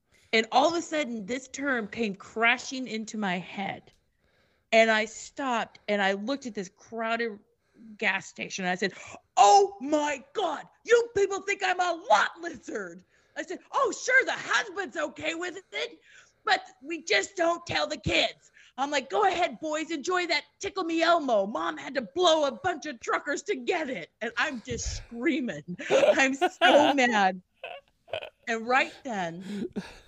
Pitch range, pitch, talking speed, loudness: 225-340 Hz, 275 Hz, 165 wpm, -27 LUFS